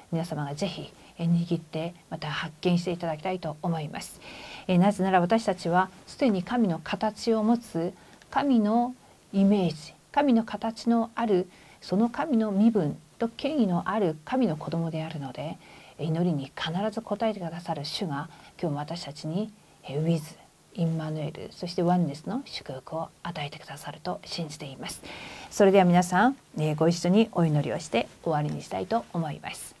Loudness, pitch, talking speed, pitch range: -28 LUFS, 180 Hz, 330 characters per minute, 160-215 Hz